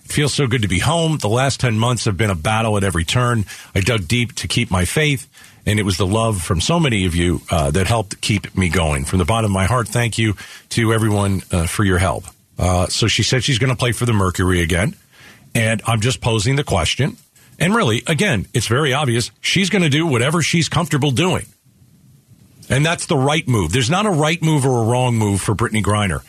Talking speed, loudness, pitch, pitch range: 235 wpm, -17 LUFS, 115 Hz, 100-135 Hz